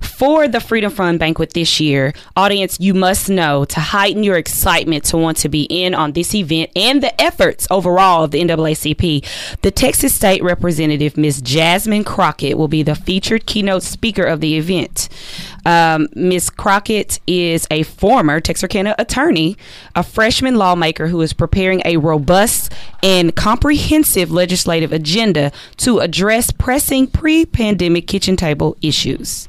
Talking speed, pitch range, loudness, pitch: 150 wpm, 160-200 Hz, -14 LUFS, 175 Hz